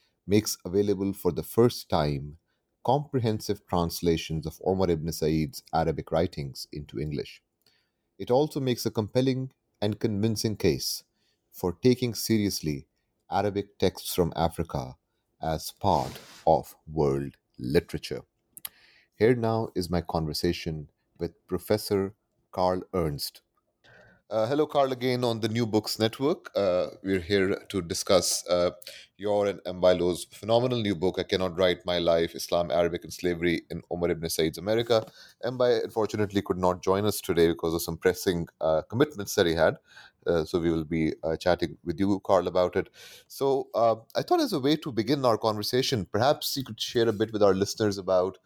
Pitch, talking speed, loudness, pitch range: 100 Hz, 160 wpm, -27 LUFS, 85-115 Hz